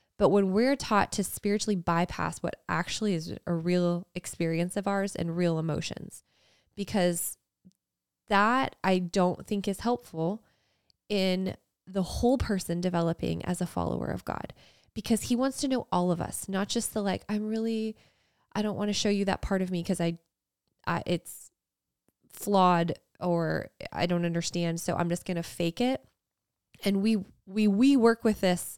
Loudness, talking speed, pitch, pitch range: -29 LUFS, 170 wpm, 190 Hz, 170-210 Hz